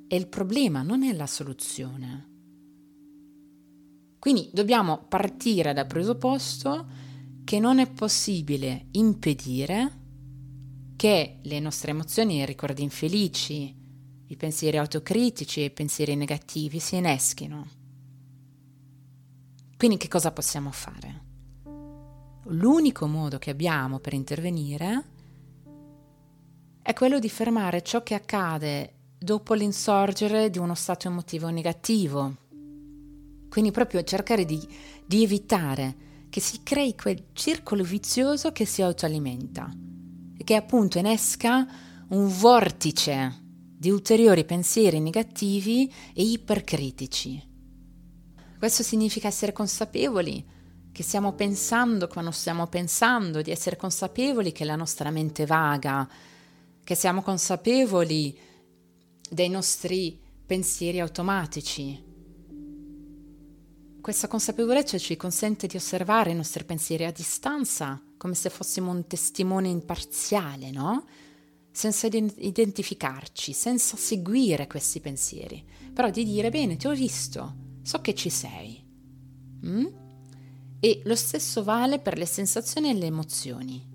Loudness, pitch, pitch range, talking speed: -26 LUFS, 160 Hz, 145-205 Hz, 110 wpm